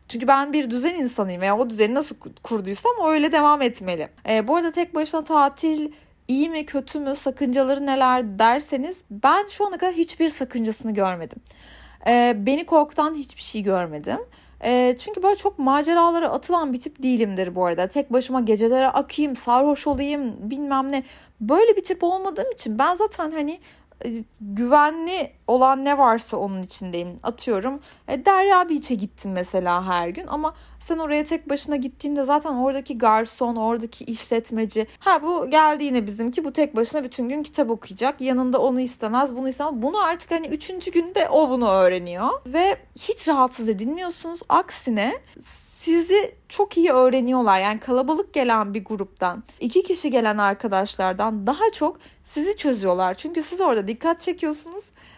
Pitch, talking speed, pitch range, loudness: 270 Hz, 155 wpm, 230-315 Hz, -22 LUFS